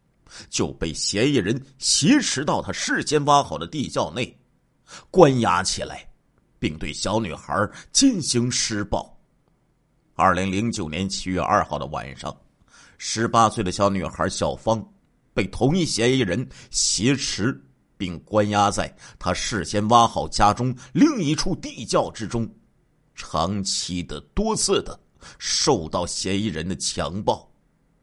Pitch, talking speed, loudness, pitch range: 105 Hz, 195 characters per minute, -22 LUFS, 95-125 Hz